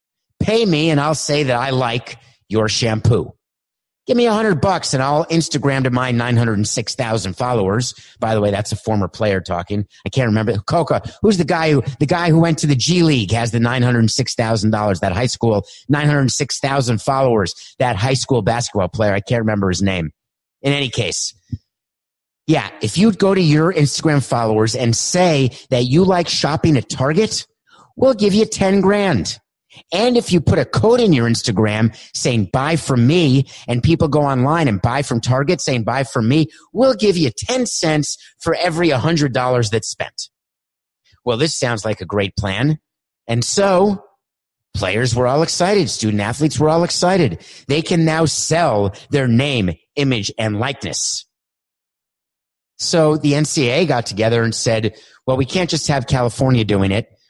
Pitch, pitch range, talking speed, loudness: 130 Hz, 110-160 Hz, 175 wpm, -17 LUFS